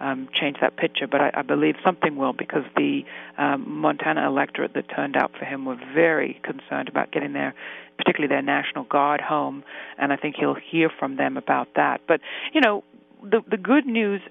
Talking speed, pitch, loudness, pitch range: 200 wpm, 150 Hz, -23 LUFS, 135-205 Hz